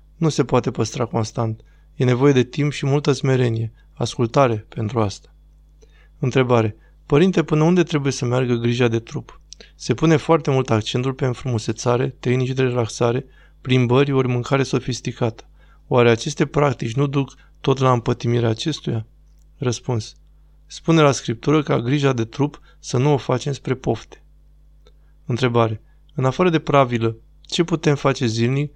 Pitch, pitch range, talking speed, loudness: 130 Hz, 115-145 Hz, 150 wpm, -20 LUFS